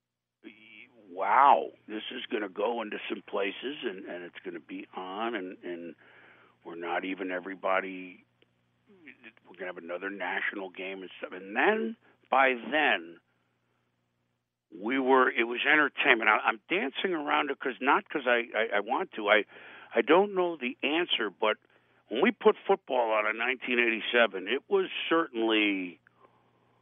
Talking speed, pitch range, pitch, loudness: 155 wpm, 90-130 Hz, 110 Hz, -28 LUFS